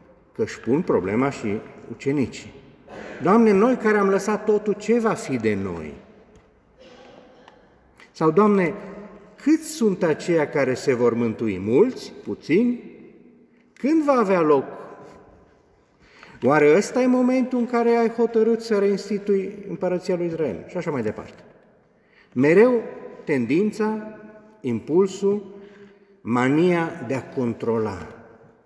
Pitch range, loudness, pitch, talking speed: 140-220 Hz, -21 LUFS, 200 Hz, 115 wpm